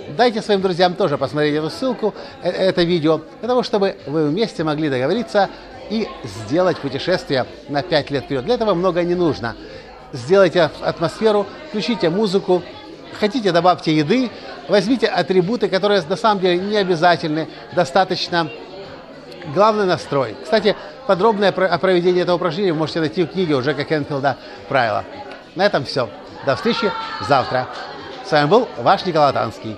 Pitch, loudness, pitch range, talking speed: 180 Hz, -18 LUFS, 155-205 Hz, 150 wpm